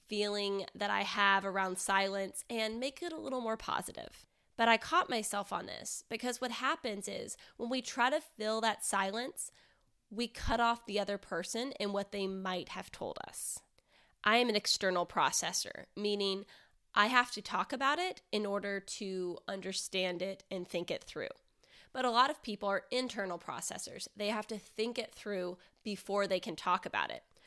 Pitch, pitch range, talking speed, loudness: 210 Hz, 195-240 Hz, 185 wpm, -35 LUFS